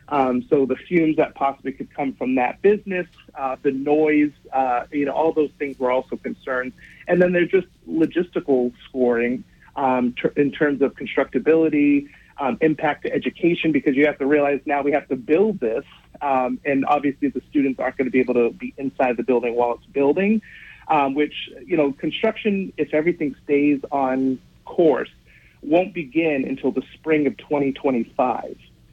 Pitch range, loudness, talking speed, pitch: 130-155 Hz, -21 LUFS, 175 wpm, 145 Hz